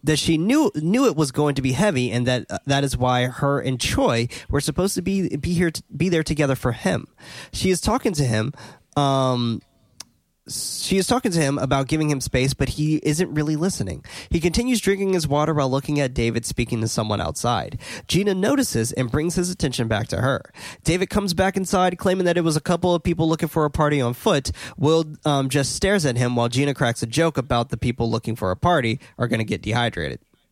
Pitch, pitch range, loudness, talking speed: 145 Hz, 125-175 Hz, -22 LUFS, 225 wpm